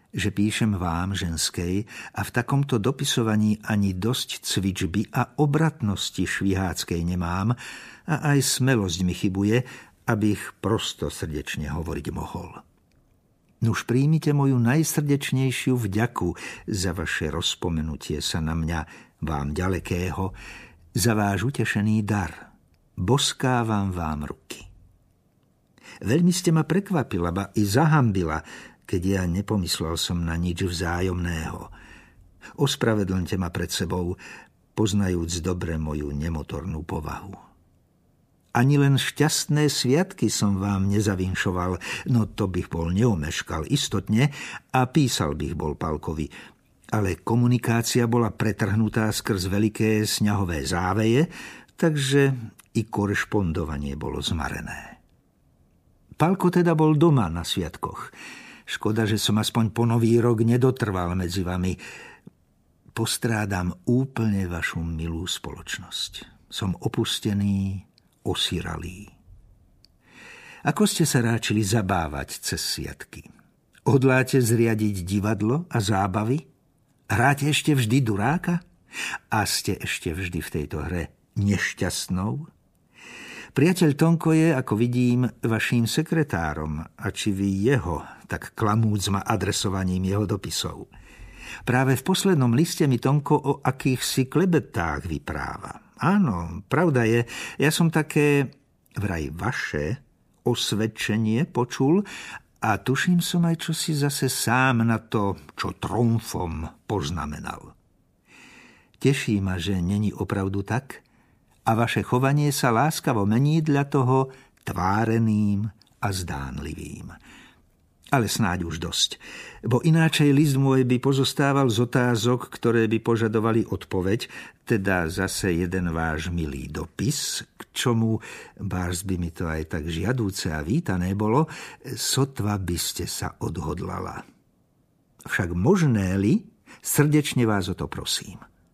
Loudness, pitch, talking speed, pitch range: -24 LUFS, 110 Hz, 115 wpm, 90-130 Hz